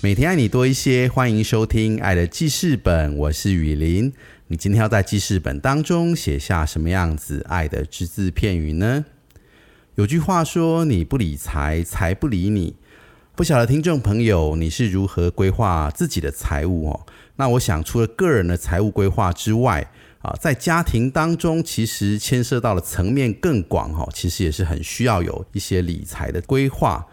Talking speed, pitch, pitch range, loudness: 265 characters per minute, 100 Hz, 85-125 Hz, -20 LUFS